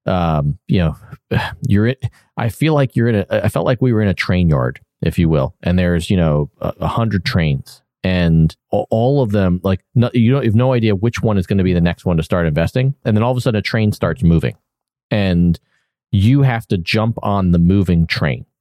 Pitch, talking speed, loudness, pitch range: 100 Hz, 240 wpm, -16 LUFS, 85-115 Hz